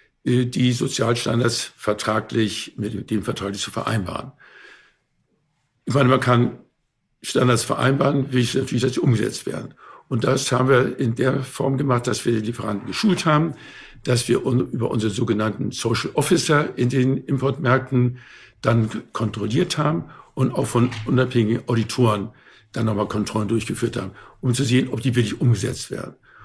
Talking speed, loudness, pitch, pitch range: 145 wpm, -21 LUFS, 120 Hz, 110-130 Hz